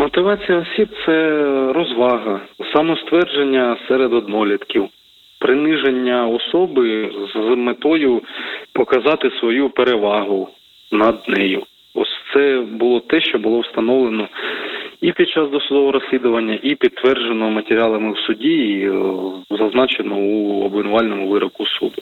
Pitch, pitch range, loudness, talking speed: 125 Hz, 110-160 Hz, -17 LUFS, 105 wpm